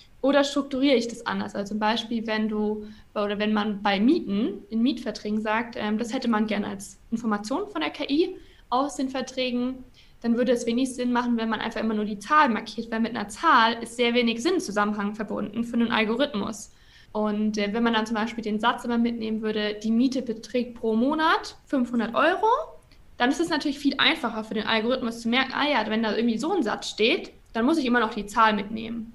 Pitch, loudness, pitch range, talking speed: 230 Hz, -25 LUFS, 215-255 Hz, 210 wpm